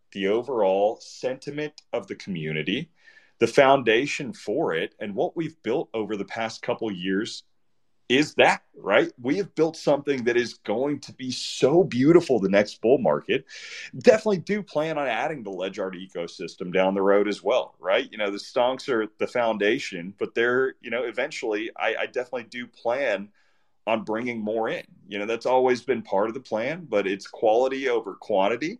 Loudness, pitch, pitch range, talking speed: -25 LUFS, 125 Hz, 110-170 Hz, 185 wpm